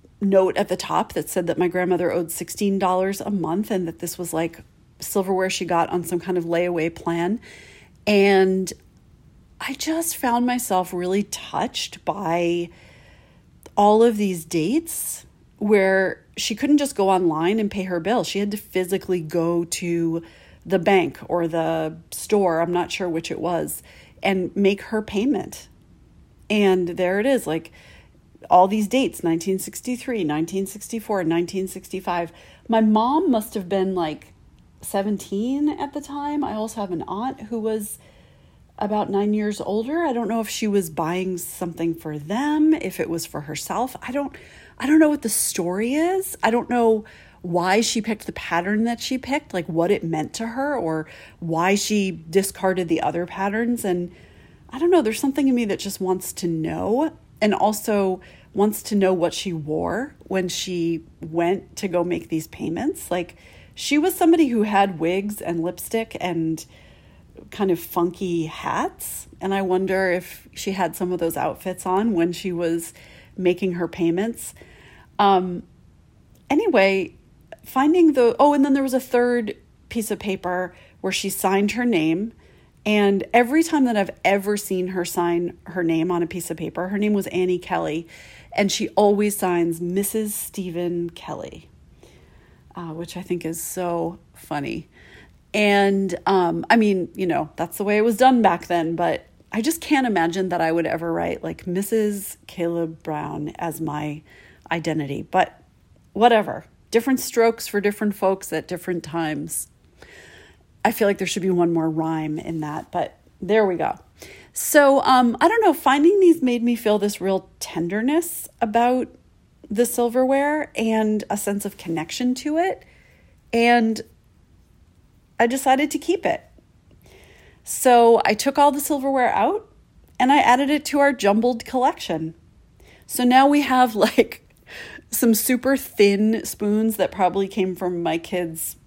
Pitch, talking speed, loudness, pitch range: 195 Hz, 165 wpm, -22 LUFS, 175-230 Hz